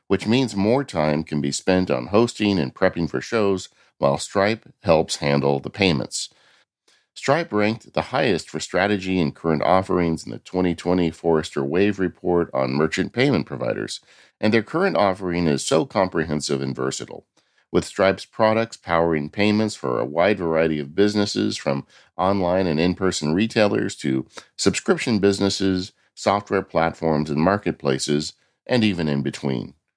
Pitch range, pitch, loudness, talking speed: 80-100 Hz, 90 Hz, -22 LUFS, 150 wpm